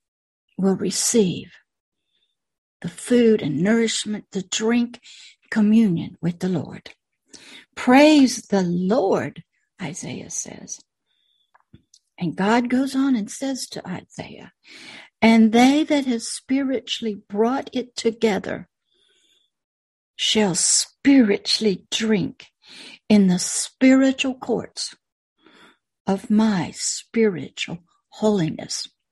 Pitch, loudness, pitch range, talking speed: 225 Hz, -20 LUFS, 195-255 Hz, 90 wpm